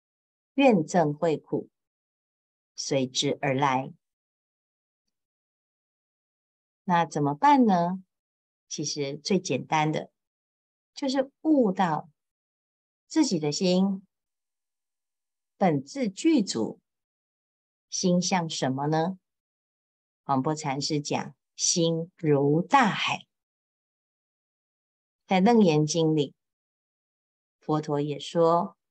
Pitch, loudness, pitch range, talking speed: 165 Hz, -26 LUFS, 145-195 Hz, 110 characters per minute